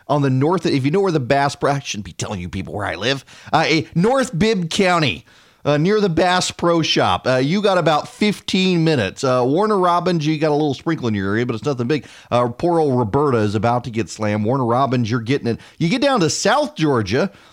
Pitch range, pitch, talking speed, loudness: 120-175 Hz, 145 Hz, 245 wpm, -18 LUFS